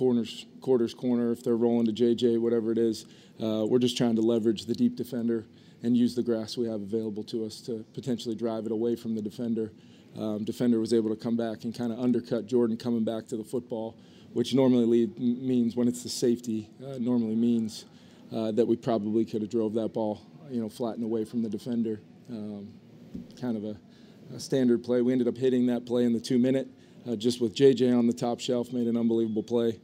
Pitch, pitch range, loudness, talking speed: 115 Hz, 110-120 Hz, -28 LUFS, 220 wpm